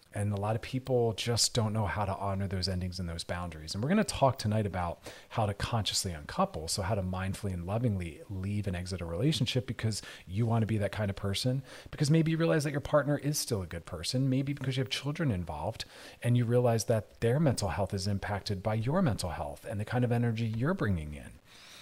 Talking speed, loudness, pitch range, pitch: 235 wpm, -32 LUFS, 95-125 Hz, 105 Hz